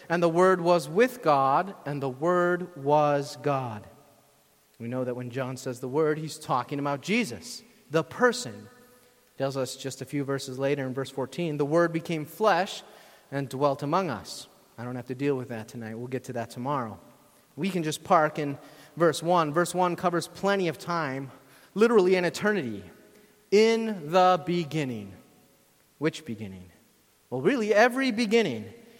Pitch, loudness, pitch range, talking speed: 155 Hz, -27 LUFS, 135-185 Hz, 170 wpm